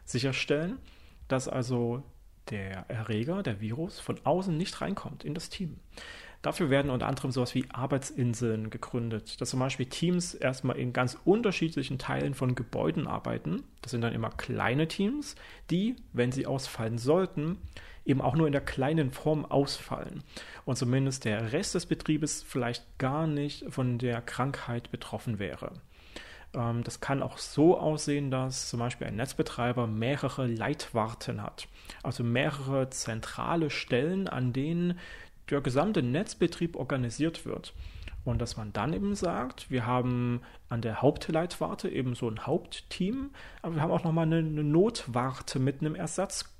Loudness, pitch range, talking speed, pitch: -31 LUFS, 120-155 Hz, 150 wpm, 130 Hz